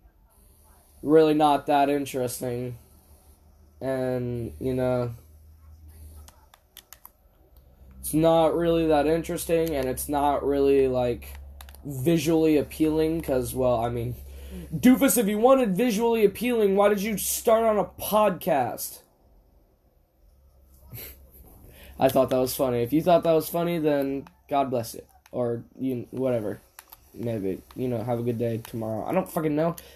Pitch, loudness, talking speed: 125 Hz, -24 LUFS, 130 wpm